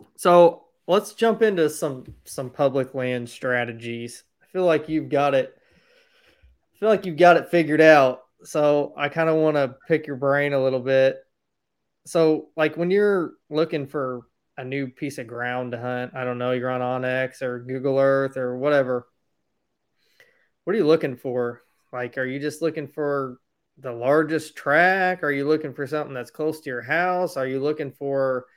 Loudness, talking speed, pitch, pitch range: -22 LUFS, 185 wpm, 145 Hz, 130-160 Hz